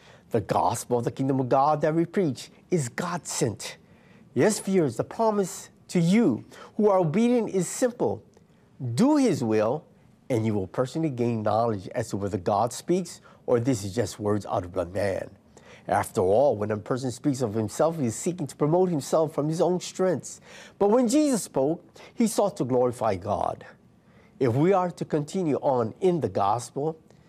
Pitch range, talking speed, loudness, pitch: 120-185 Hz, 180 wpm, -26 LUFS, 155 Hz